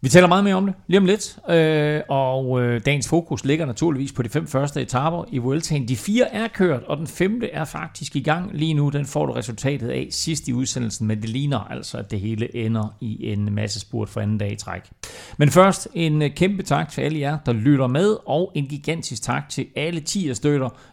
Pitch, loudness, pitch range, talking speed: 145 Hz, -22 LUFS, 125-165 Hz, 230 wpm